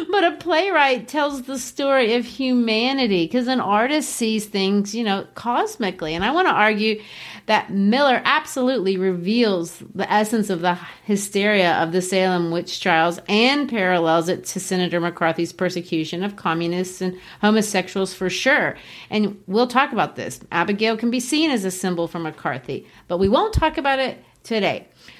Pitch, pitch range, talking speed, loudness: 205 Hz, 180-250 Hz, 165 wpm, -20 LUFS